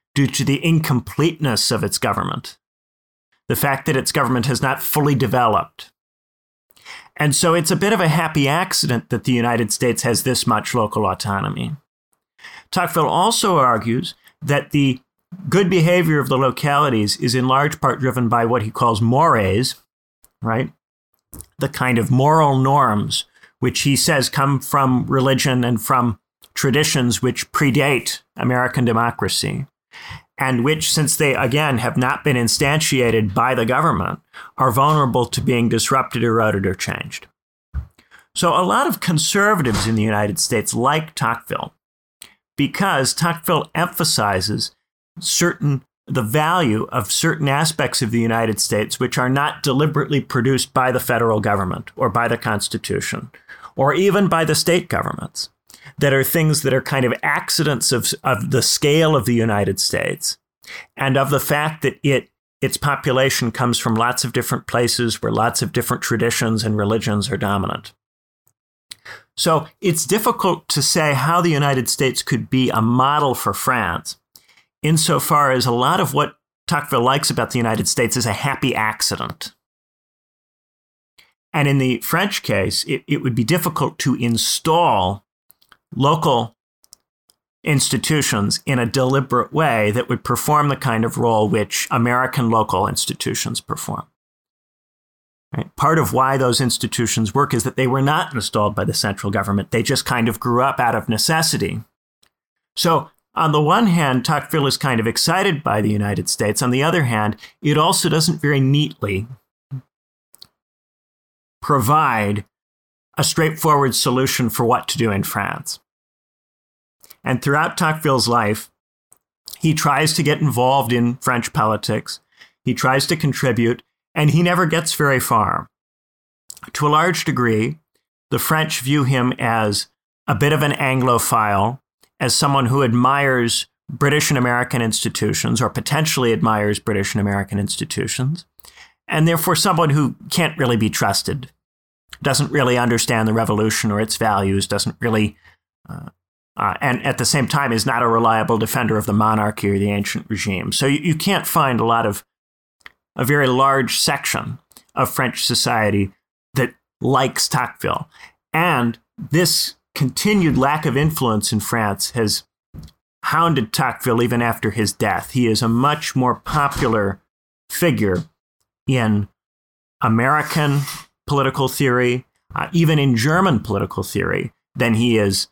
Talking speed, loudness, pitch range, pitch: 150 wpm, -18 LUFS, 115-145 Hz, 130 Hz